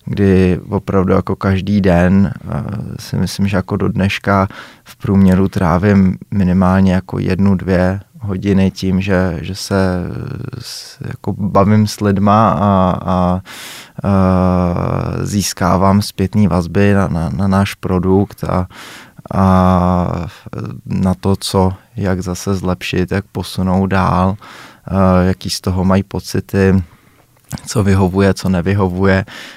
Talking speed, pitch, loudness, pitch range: 120 wpm, 95 Hz, -15 LUFS, 95-100 Hz